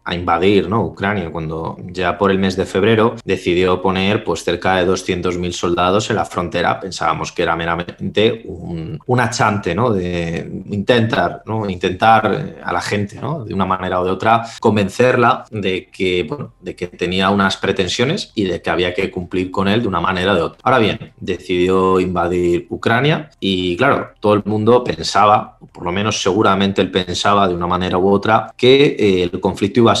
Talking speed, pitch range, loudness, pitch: 185 wpm, 90-110 Hz, -16 LUFS, 95 Hz